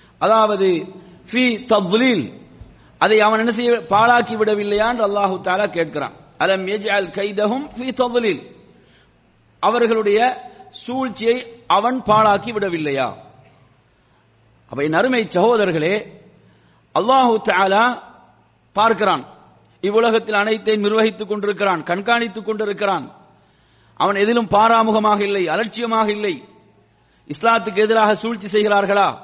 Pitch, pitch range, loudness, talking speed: 215 Hz, 205-230 Hz, -18 LUFS, 80 wpm